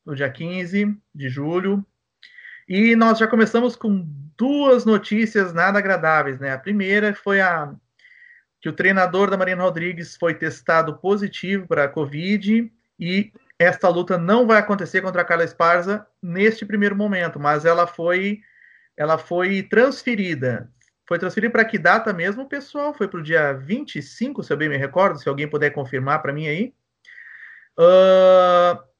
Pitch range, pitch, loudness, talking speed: 165-220 Hz, 190 Hz, -19 LUFS, 155 wpm